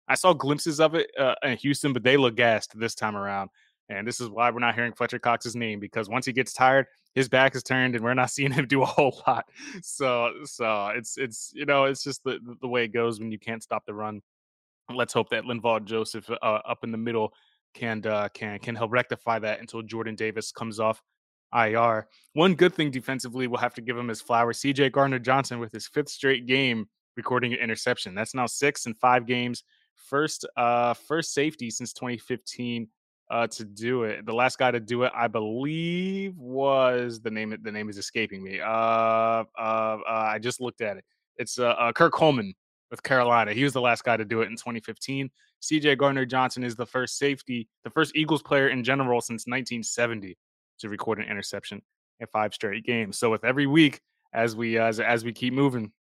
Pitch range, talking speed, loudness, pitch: 115-130 Hz, 210 wpm, -26 LUFS, 120 Hz